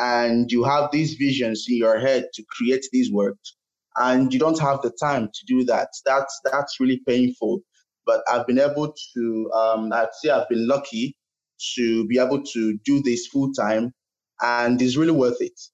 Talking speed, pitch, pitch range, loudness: 185 wpm, 125 Hz, 115-140 Hz, -22 LUFS